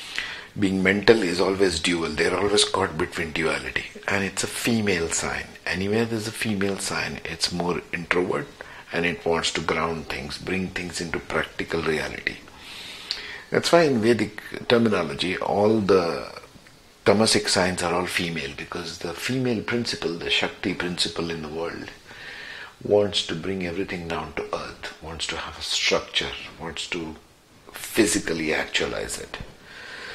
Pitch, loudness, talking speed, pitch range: 95 Hz, -24 LUFS, 145 wpm, 85-105 Hz